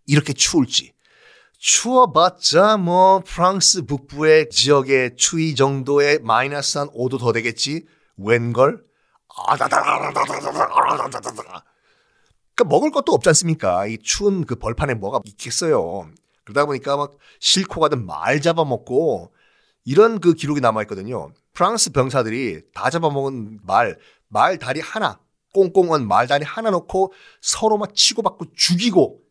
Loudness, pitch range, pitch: -18 LUFS, 135-190 Hz, 155 Hz